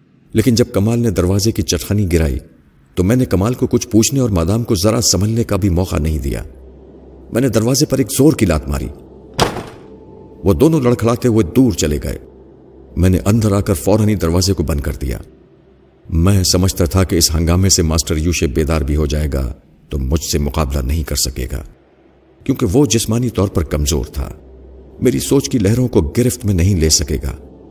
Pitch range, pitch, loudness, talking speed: 75-110 Hz, 90 Hz, -15 LUFS, 200 wpm